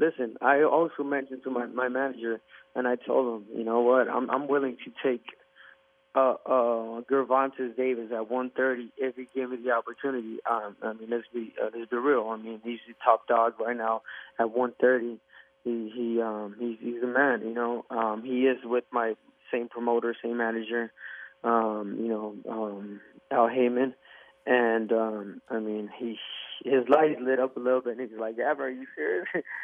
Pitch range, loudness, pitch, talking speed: 115-130 Hz, -28 LUFS, 120 Hz, 190 wpm